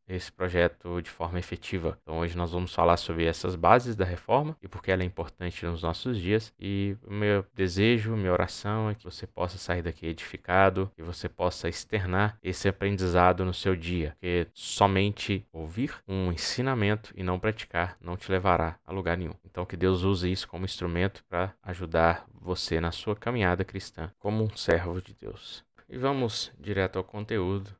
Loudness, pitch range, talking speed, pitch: -29 LUFS, 90-105 Hz, 185 wpm, 95 Hz